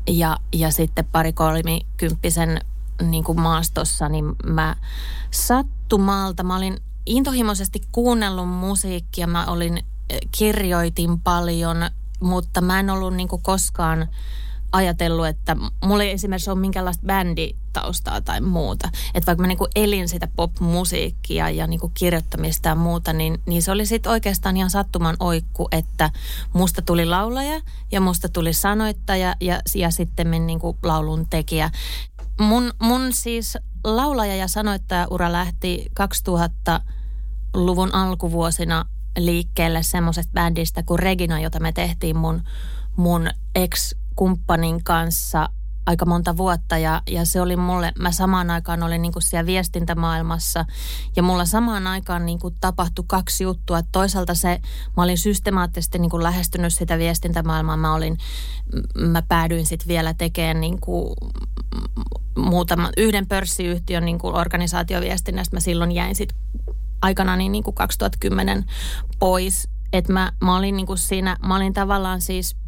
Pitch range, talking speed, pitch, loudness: 165-185 Hz, 130 wpm, 175 Hz, -21 LUFS